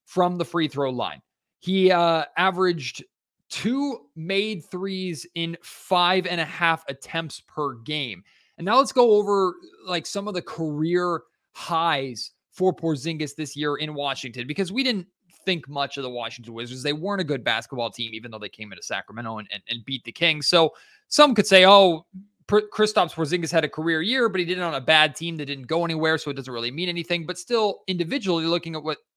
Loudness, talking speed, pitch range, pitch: -23 LUFS, 200 wpm, 145-185 Hz, 165 Hz